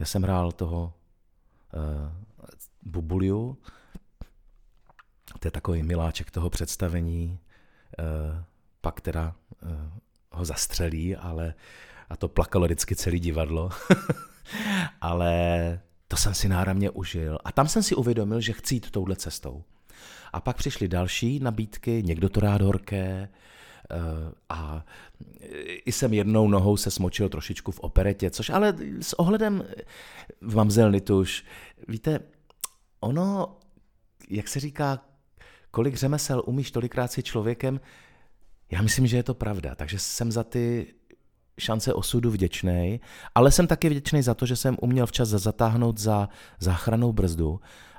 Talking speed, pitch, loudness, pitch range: 130 wpm, 100 Hz, -27 LUFS, 85-120 Hz